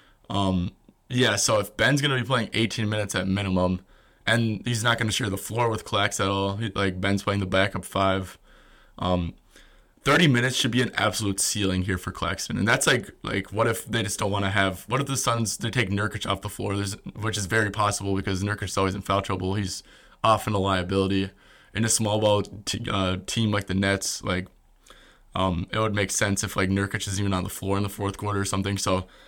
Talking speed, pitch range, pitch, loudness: 220 wpm, 95-110 Hz, 100 Hz, -25 LUFS